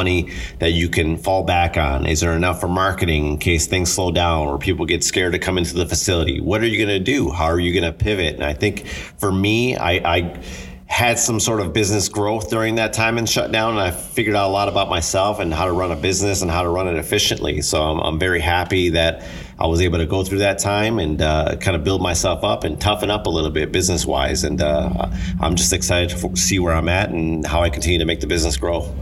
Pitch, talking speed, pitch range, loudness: 90 Hz, 250 wpm, 85-100 Hz, -19 LUFS